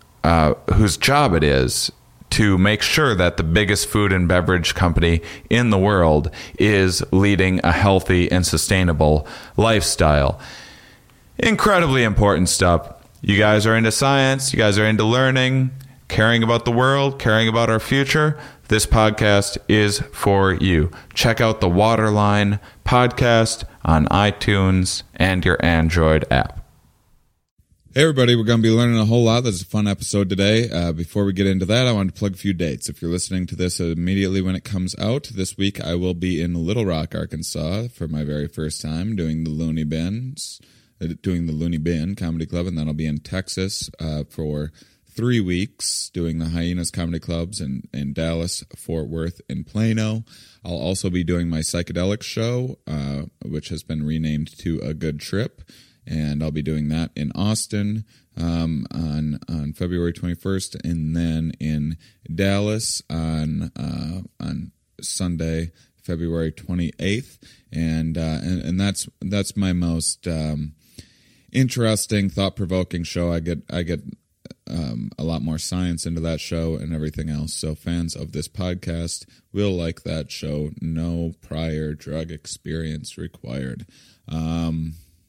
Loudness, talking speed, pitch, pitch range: -20 LUFS, 160 wpm, 90 Hz, 80-105 Hz